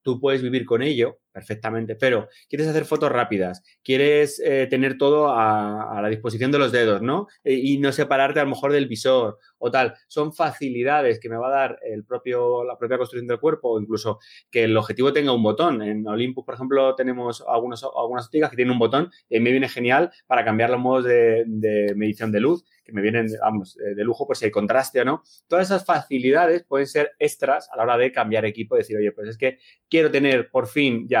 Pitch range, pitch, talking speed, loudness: 115-140 Hz, 125 Hz, 225 wpm, -22 LUFS